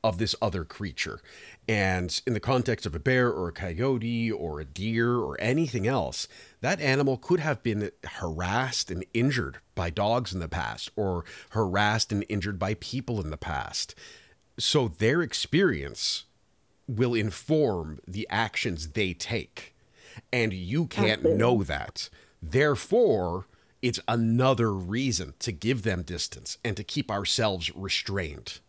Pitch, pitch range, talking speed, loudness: 110 Hz, 95-125 Hz, 145 wpm, -28 LUFS